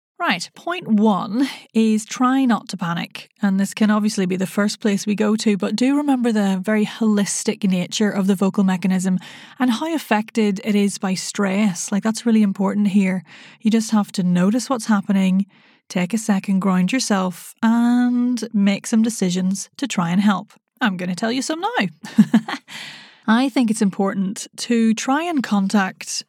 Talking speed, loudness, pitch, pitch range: 175 wpm, -20 LUFS, 210 Hz, 195-230 Hz